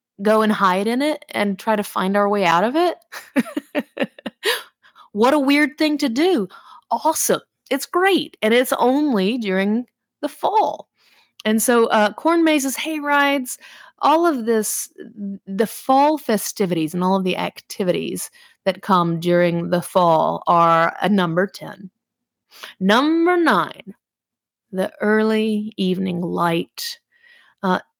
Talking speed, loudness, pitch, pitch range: 135 wpm, -19 LUFS, 230 Hz, 195-295 Hz